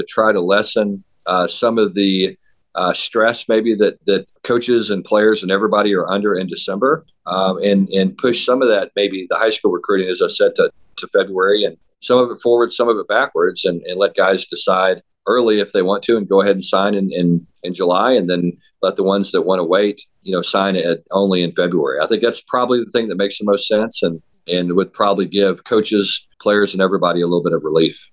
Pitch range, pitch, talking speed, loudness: 95-115 Hz, 100 Hz, 235 wpm, -16 LUFS